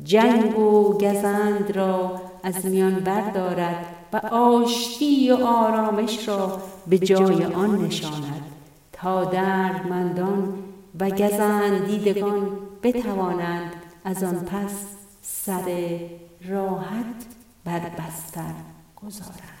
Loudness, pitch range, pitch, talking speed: -23 LUFS, 180-205 Hz, 190 Hz, 90 wpm